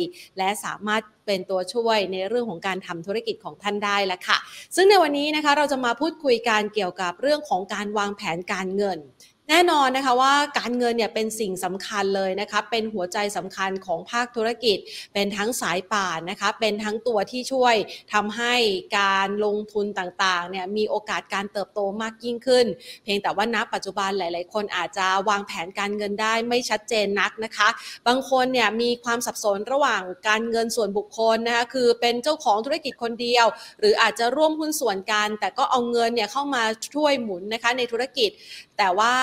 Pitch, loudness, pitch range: 215 Hz, -23 LUFS, 200-240 Hz